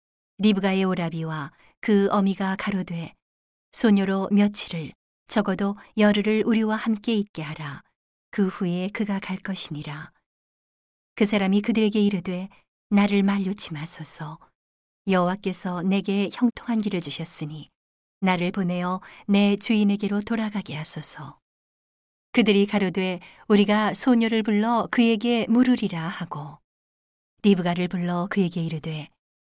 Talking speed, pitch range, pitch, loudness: 275 characters per minute, 175-210 Hz, 195 Hz, -24 LUFS